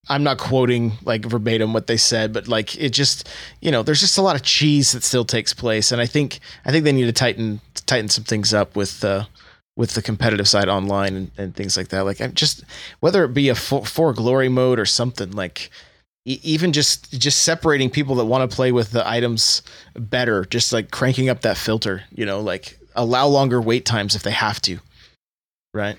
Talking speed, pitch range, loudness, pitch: 220 wpm, 110-135 Hz, -19 LUFS, 120 Hz